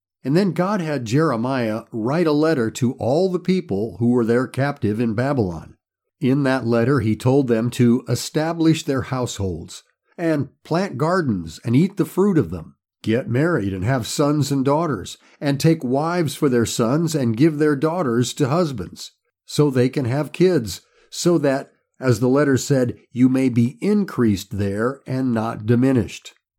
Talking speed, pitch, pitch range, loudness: 170 wpm, 130 Hz, 115-150 Hz, -20 LUFS